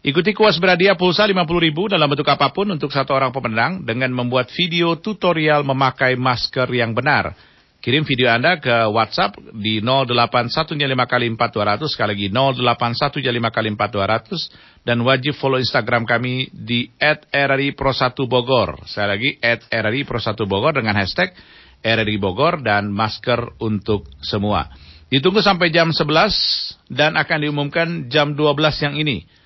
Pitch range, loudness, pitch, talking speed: 115-150 Hz, -18 LUFS, 130 Hz, 140 wpm